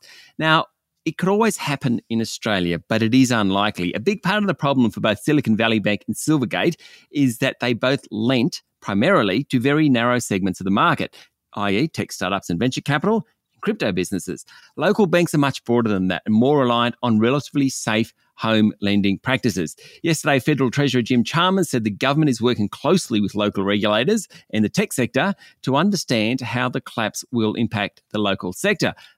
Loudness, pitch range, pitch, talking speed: -20 LUFS, 110-150 Hz, 125 Hz, 185 wpm